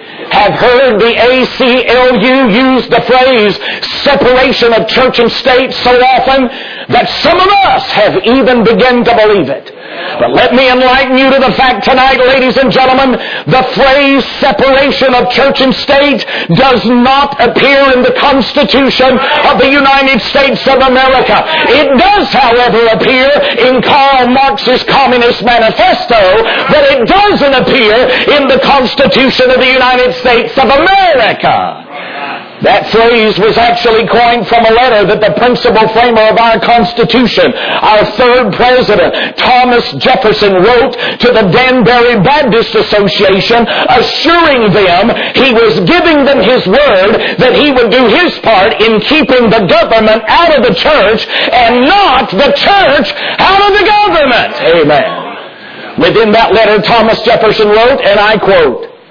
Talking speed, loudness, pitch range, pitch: 145 wpm, -6 LUFS, 230-270 Hz, 250 Hz